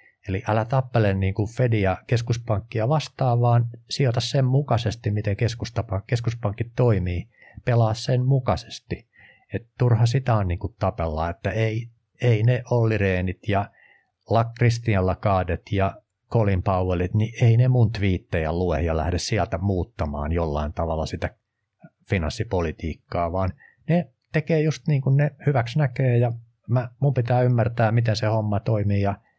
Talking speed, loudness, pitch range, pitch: 135 wpm, -23 LUFS, 95-120 Hz, 110 Hz